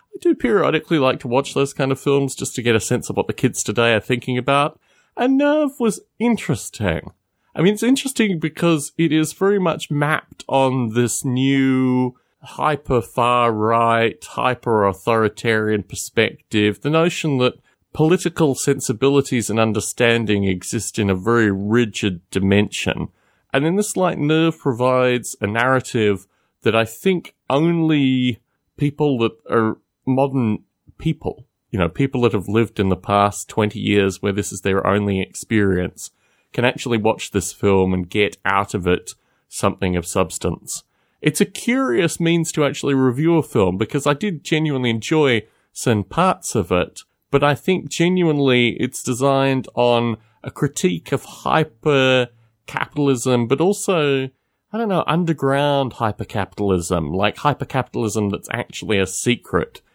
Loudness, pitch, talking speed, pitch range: -19 LUFS, 125 Hz, 145 wpm, 110-150 Hz